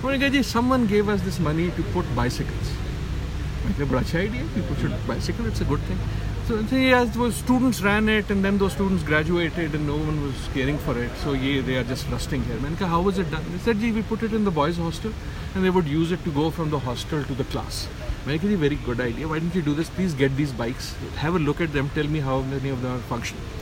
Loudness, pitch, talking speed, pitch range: -24 LUFS, 150 Hz, 240 wpm, 125-185 Hz